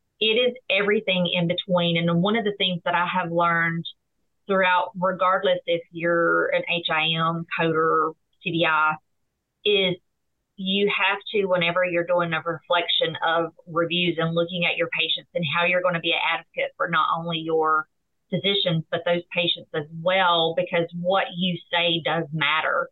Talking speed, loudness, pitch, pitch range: 160 wpm, -23 LUFS, 175 Hz, 165-185 Hz